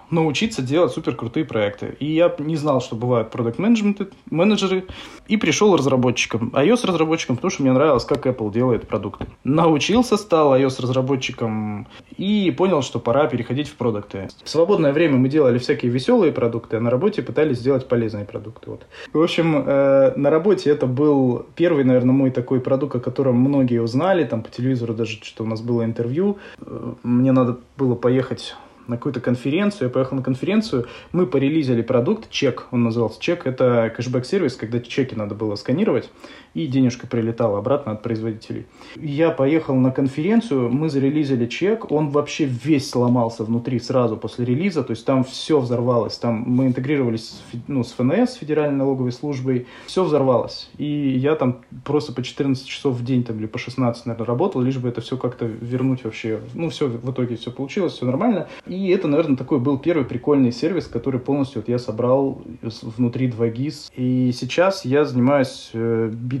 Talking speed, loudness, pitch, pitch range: 175 wpm, -20 LUFS, 130 Hz, 120-150 Hz